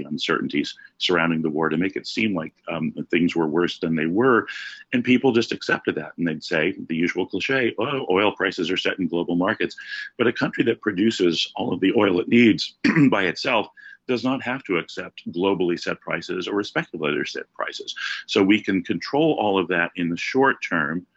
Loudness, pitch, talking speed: -22 LUFS, 115 Hz, 200 wpm